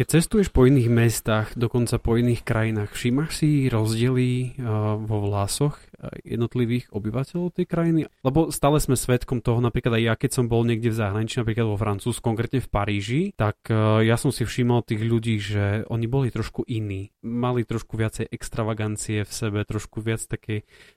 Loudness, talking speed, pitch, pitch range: -24 LUFS, 170 wpm, 115 Hz, 110-125 Hz